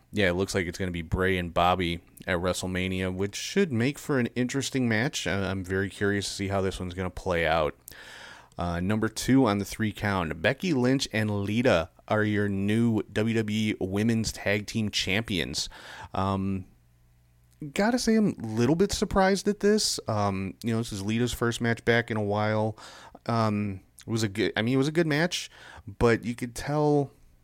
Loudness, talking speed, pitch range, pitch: -27 LUFS, 195 wpm, 95-125 Hz, 105 Hz